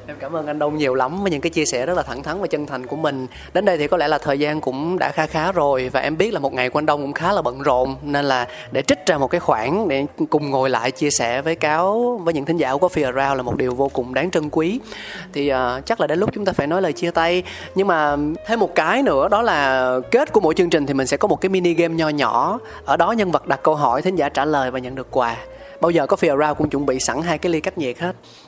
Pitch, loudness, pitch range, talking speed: 150 Hz, -19 LUFS, 130-170 Hz, 305 wpm